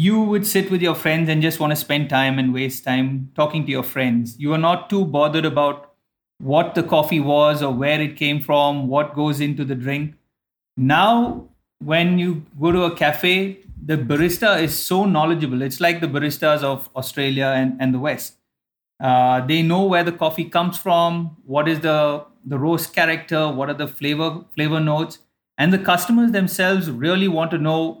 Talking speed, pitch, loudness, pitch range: 190 wpm, 155 Hz, -19 LUFS, 145-170 Hz